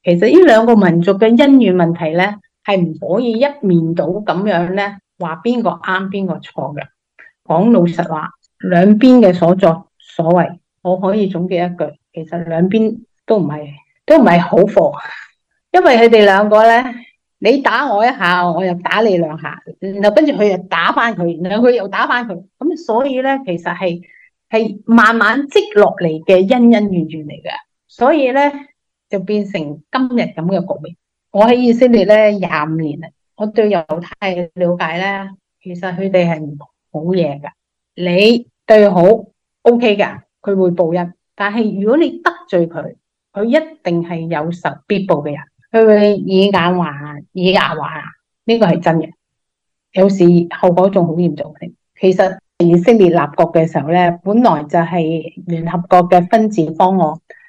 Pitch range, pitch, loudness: 170-220 Hz, 185 Hz, -13 LUFS